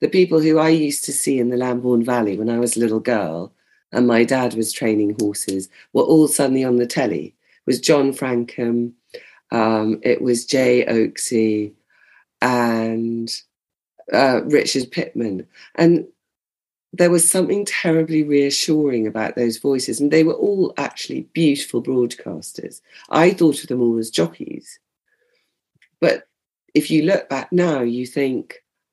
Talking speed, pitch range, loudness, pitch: 150 wpm, 115-155 Hz, -18 LUFS, 125 Hz